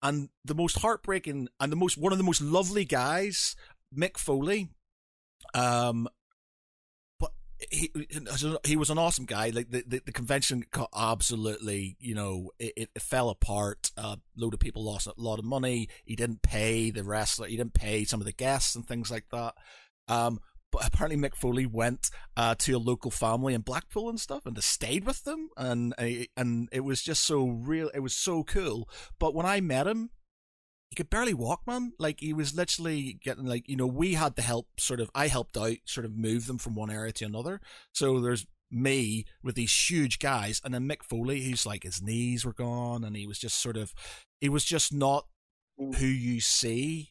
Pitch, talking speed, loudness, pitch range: 125 Hz, 205 wpm, -30 LUFS, 115-150 Hz